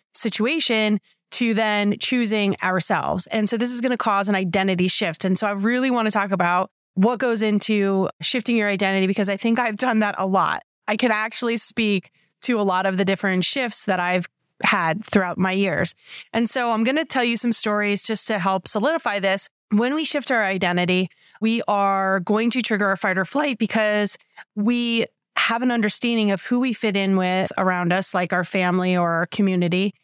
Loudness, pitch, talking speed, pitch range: -19 LUFS, 210 Hz, 200 wpm, 190-230 Hz